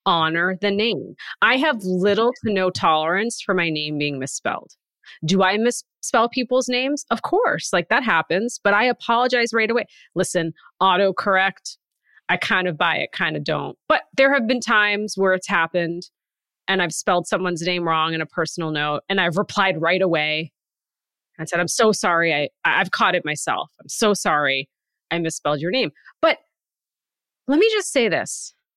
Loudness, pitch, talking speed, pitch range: -20 LUFS, 190 Hz, 175 wpm, 170-230 Hz